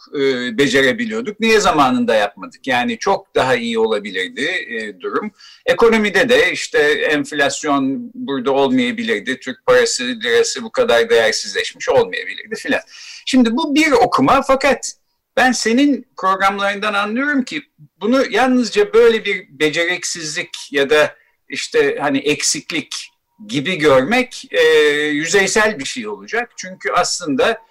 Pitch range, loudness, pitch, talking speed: 195-295 Hz, -16 LUFS, 245 Hz, 115 wpm